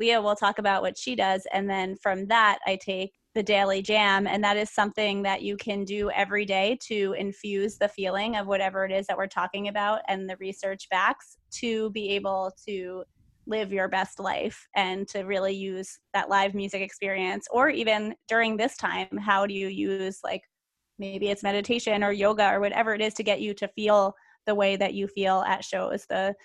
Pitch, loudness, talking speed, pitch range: 200 Hz, -27 LUFS, 205 wpm, 195-210 Hz